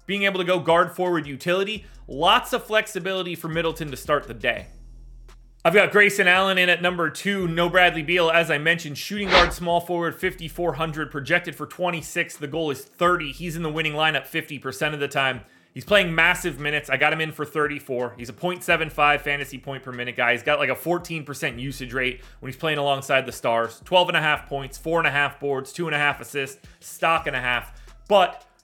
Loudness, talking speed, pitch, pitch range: -22 LUFS, 215 wpm, 160 Hz, 140-175 Hz